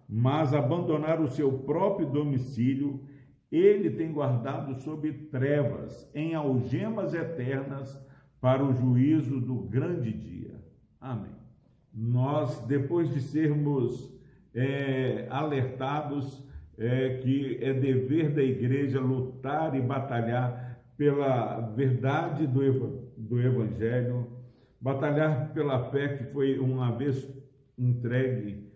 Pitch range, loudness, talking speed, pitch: 125-145 Hz, -29 LUFS, 105 wpm, 135 Hz